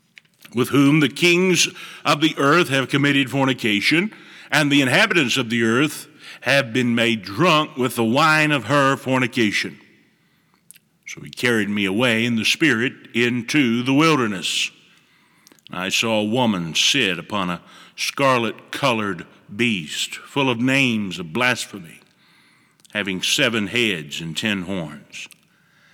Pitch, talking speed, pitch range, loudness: 130 Hz, 135 wpm, 115-145 Hz, -19 LUFS